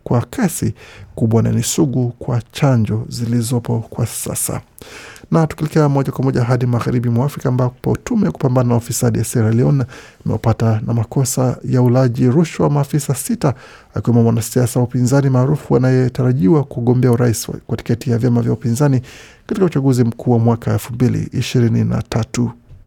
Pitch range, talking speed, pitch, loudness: 115-135 Hz, 150 wpm, 125 Hz, -16 LUFS